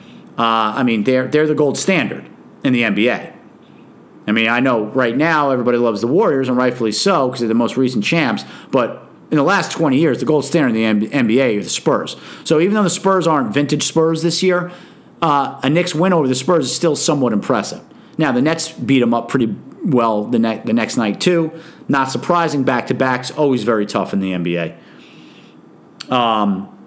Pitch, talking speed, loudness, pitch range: 130 Hz, 205 wpm, -16 LUFS, 115-160 Hz